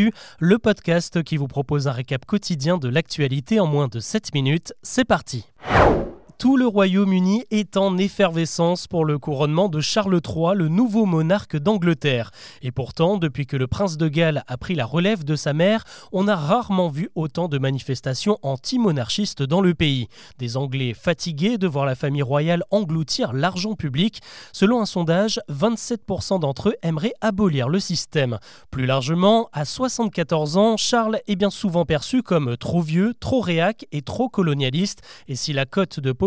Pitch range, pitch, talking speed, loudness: 145-205 Hz, 170 Hz, 170 wpm, -21 LUFS